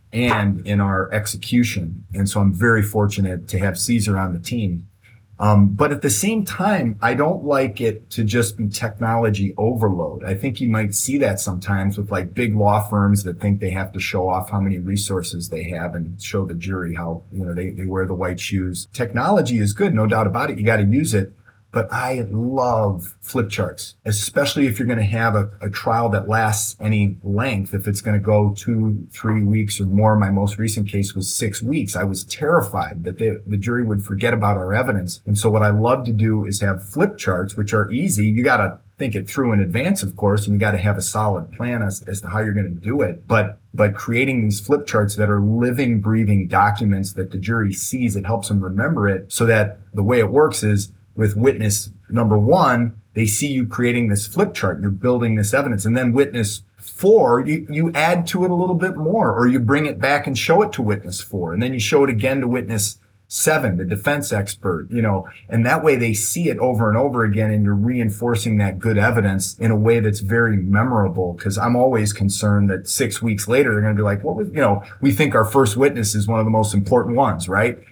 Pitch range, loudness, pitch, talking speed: 100-120 Hz, -19 LUFS, 105 Hz, 230 wpm